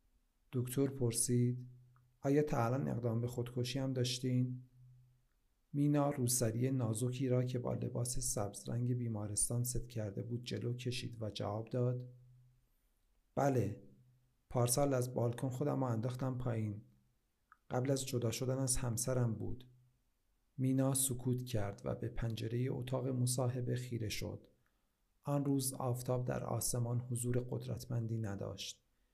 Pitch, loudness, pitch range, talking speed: 125 Hz, -38 LUFS, 120-125 Hz, 120 wpm